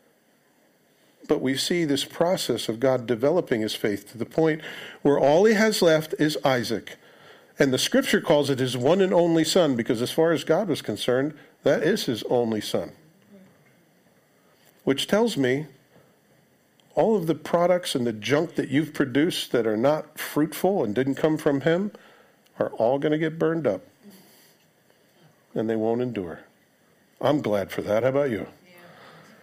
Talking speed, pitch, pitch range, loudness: 165 wpm, 155 Hz, 130-175 Hz, -24 LUFS